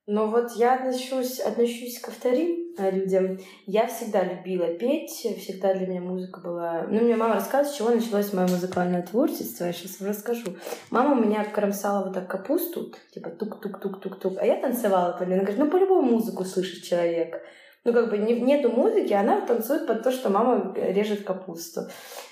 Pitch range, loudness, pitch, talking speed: 190-245 Hz, -25 LUFS, 210 Hz, 175 wpm